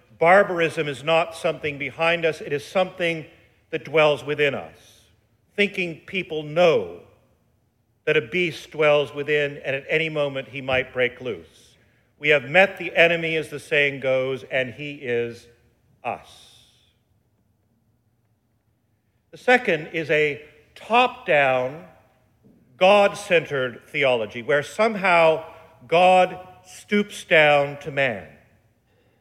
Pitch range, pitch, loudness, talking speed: 120-165 Hz, 145 Hz, -21 LUFS, 120 wpm